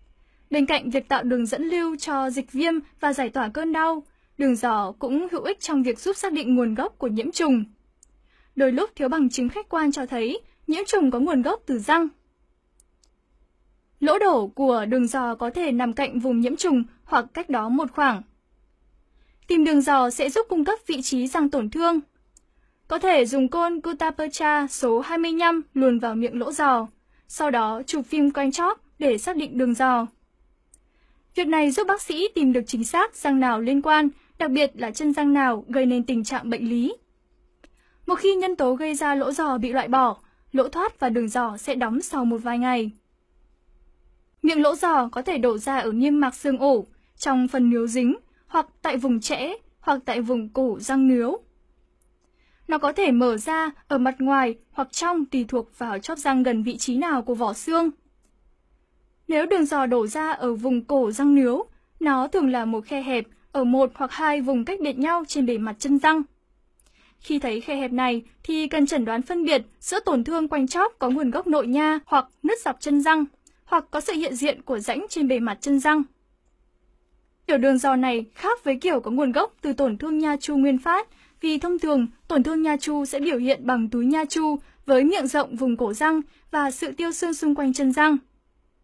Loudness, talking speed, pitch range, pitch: -23 LUFS, 205 wpm, 250-315 Hz, 275 Hz